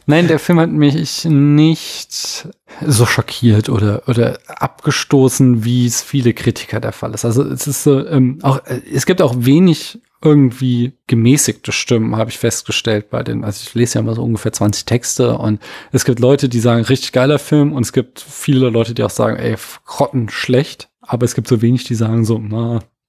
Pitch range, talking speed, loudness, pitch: 115-140 Hz, 190 wpm, -14 LUFS, 125 Hz